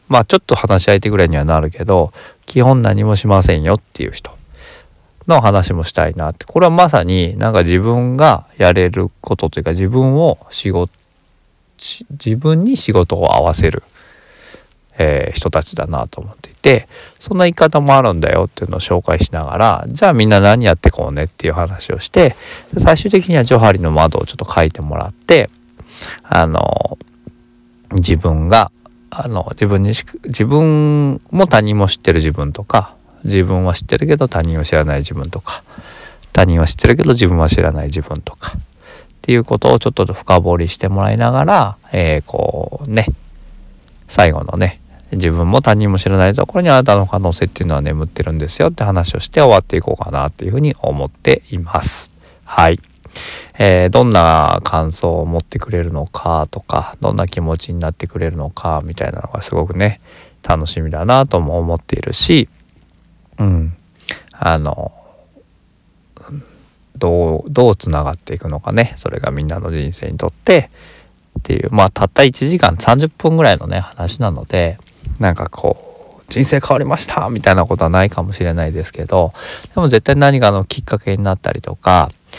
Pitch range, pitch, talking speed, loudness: 85-120 Hz, 95 Hz, 345 characters per minute, -14 LUFS